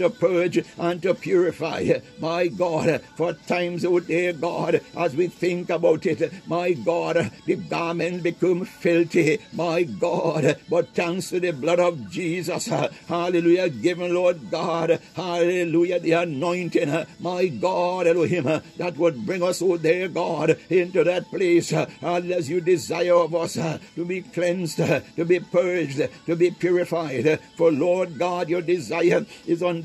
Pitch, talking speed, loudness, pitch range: 175 Hz, 150 wpm, -23 LUFS, 165-180 Hz